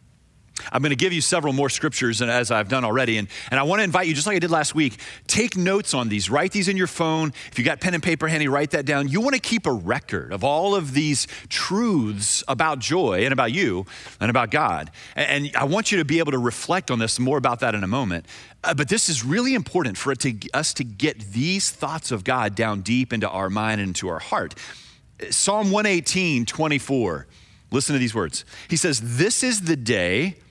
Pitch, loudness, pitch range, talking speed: 140 Hz, -22 LUFS, 120-175 Hz, 235 wpm